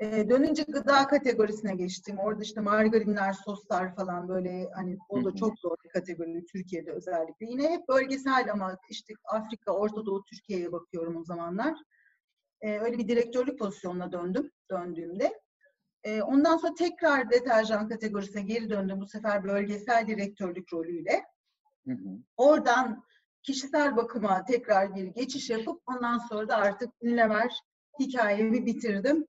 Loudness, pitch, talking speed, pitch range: -29 LUFS, 215 Hz, 135 wpm, 195-255 Hz